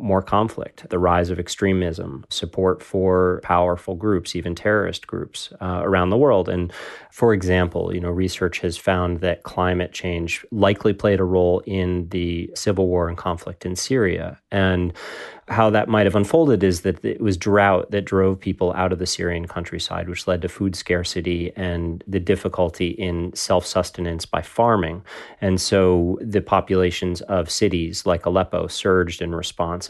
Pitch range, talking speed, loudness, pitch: 90-95 Hz, 165 wpm, -21 LUFS, 90 Hz